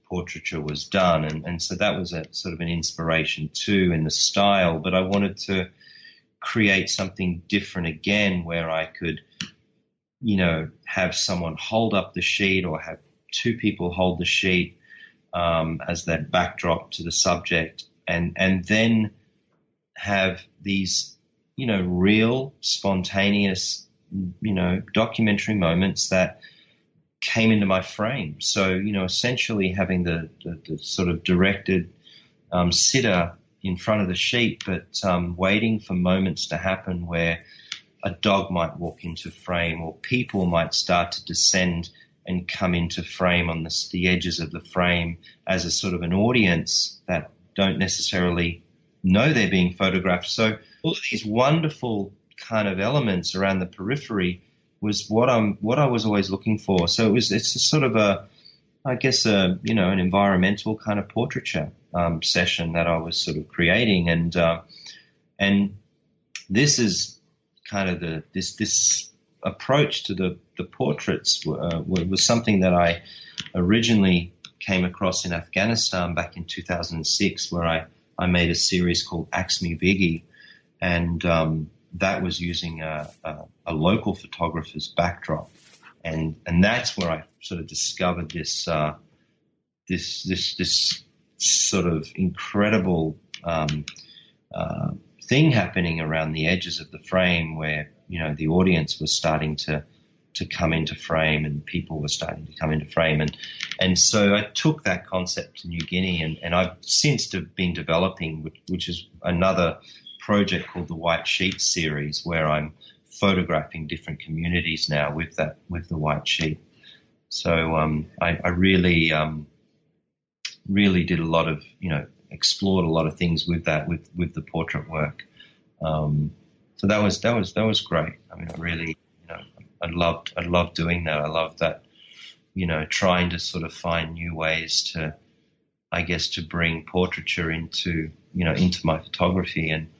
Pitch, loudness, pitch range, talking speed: 90 Hz, -23 LUFS, 80-95 Hz, 160 wpm